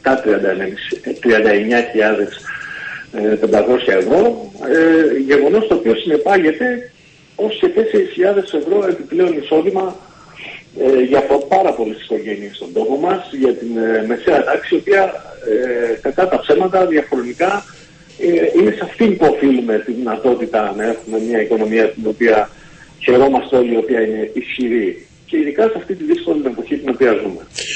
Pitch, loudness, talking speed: 145 Hz, -15 LUFS, 130 wpm